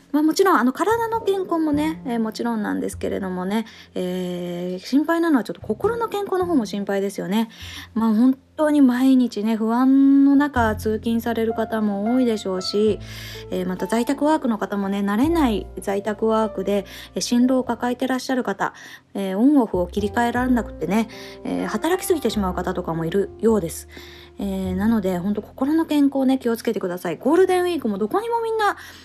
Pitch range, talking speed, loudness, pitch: 195-275 Hz, 395 characters per minute, -21 LUFS, 225 Hz